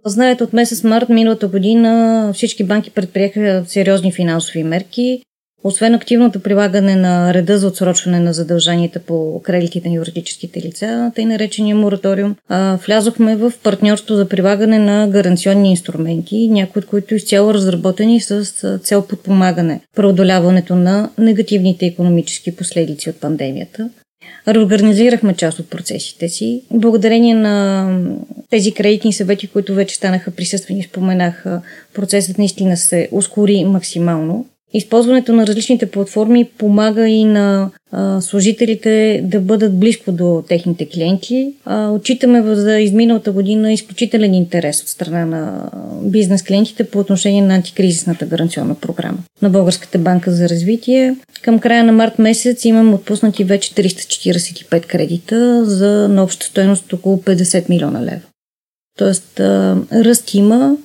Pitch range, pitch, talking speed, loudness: 180-220 Hz, 200 Hz, 130 wpm, -13 LUFS